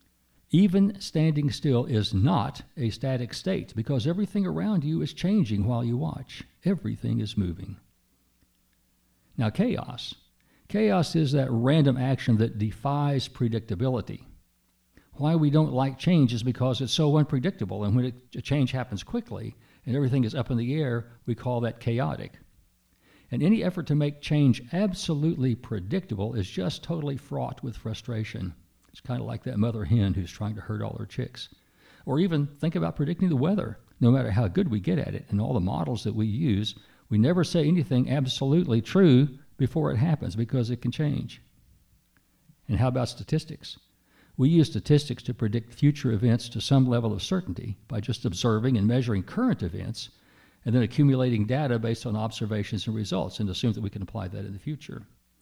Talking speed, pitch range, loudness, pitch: 175 wpm, 110-145 Hz, -26 LUFS, 125 Hz